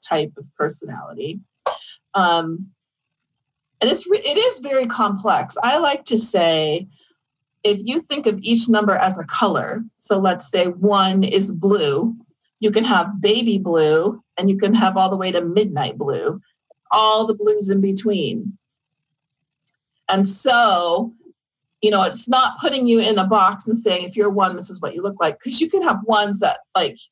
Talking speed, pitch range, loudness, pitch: 175 wpm, 180-225 Hz, -18 LUFS, 205 Hz